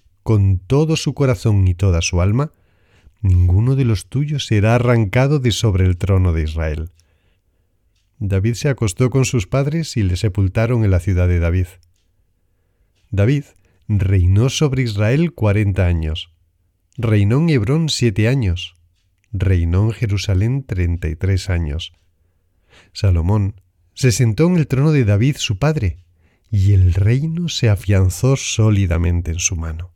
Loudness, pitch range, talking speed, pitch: -17 LUFS, 90-120 Hz, 140 wpm, 100 Hz